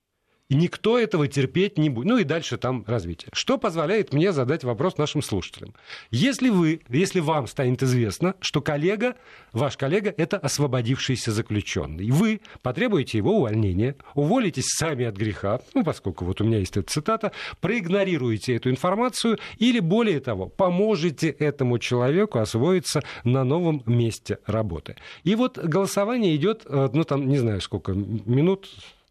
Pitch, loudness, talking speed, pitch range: 150 Hz, -24 LUFS, 145 wpm, 120-195 Hz